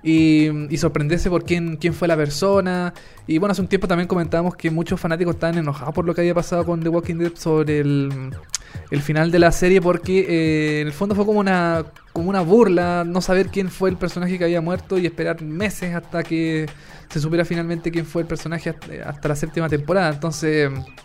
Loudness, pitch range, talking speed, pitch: -20 LUFS, 160-180 Hz, 215 wpm, 170 Hz